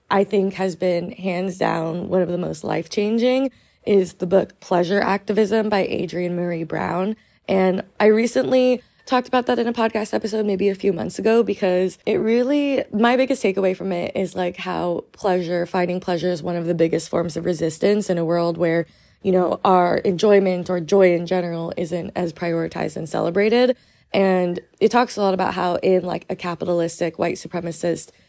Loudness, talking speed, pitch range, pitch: -21 LUFS, 185 wpm, 175-210 Hz, 185 Hz